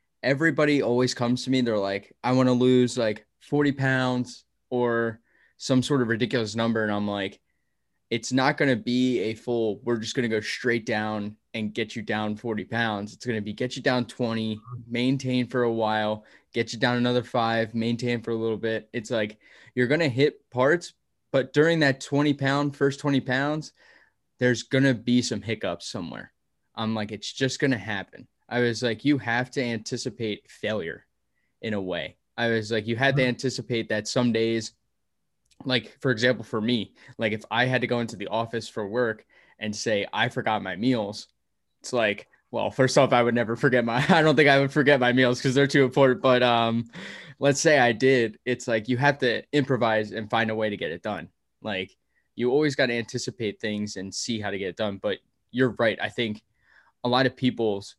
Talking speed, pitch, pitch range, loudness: 210 wpm, 120 Hz, 115-130 Hz, -25 LUFS